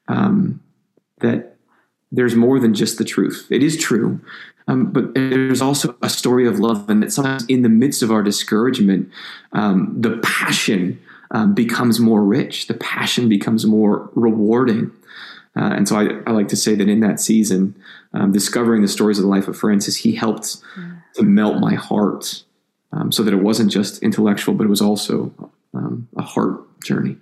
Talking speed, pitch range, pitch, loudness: 180 wpm, 105-125 Hz, 110 Hz, -17 LUFS